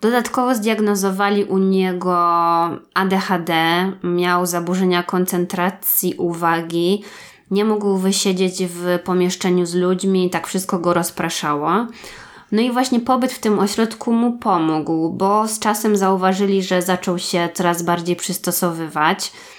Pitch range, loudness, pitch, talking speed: 175-205 Hz, -18 LUFS, 185 Hz, 120 wpm